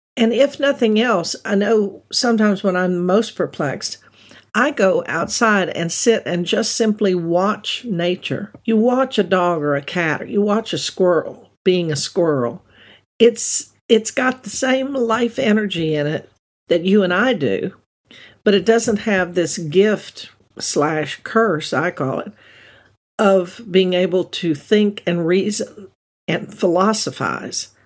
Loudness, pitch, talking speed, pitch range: -18 LUFS, 200 Hz, 150 wpm, 175-225 Hz